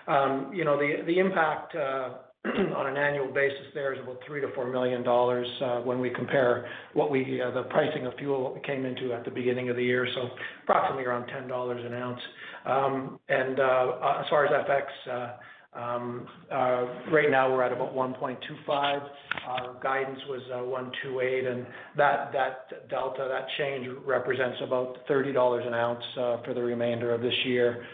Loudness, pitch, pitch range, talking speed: -29 LUFS, 125 Hz, 125-135 Hz, 185 wpm